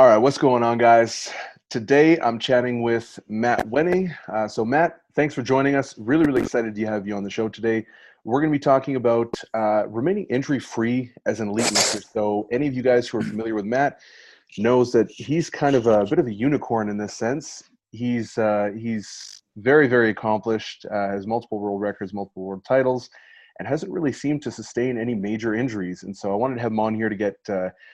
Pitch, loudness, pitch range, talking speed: 115 Hz, -22 LUFS, 105-130 Hz, 215 wpm